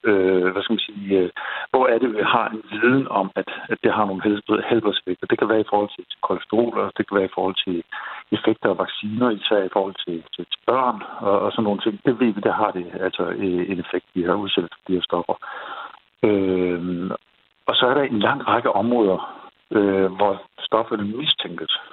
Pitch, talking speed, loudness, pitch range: 100 Hz, 195 wpm, -22 LUFS, 95-110 Hz